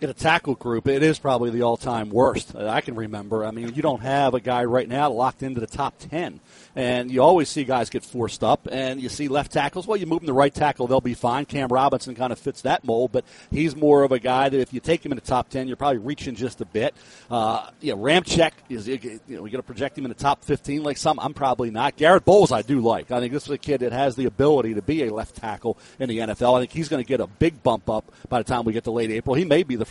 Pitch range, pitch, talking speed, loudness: 120-145 Hz, 130 Hz, 285 wpm, -23 LUFS